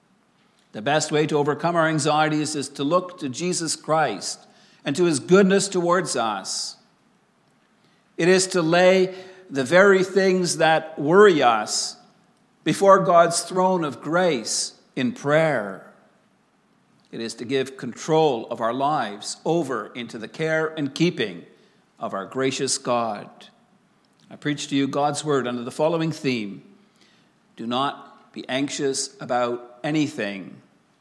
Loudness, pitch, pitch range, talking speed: -22 LUFS, 155 Hz, 135-180 Hz, 135 wpm